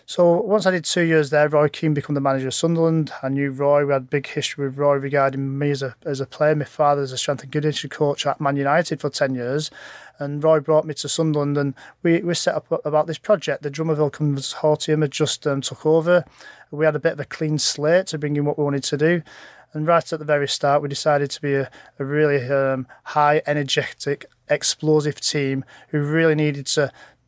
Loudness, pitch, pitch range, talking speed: -21 LUFS, 150 Hz, 140-155 Hz, 230 wpm